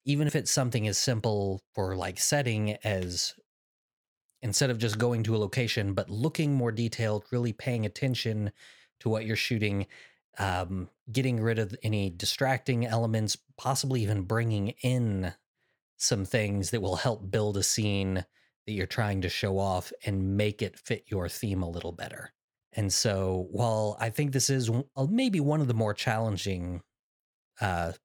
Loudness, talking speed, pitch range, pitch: -29 LUFS, 165 wpm, 100-125 Hz, 110 Hz